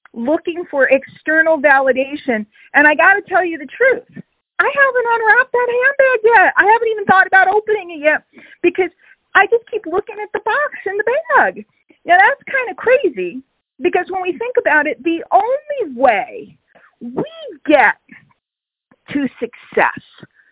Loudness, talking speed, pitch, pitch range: -14 LUFS, 160 wpm, 365 Hz, 295-425 Hz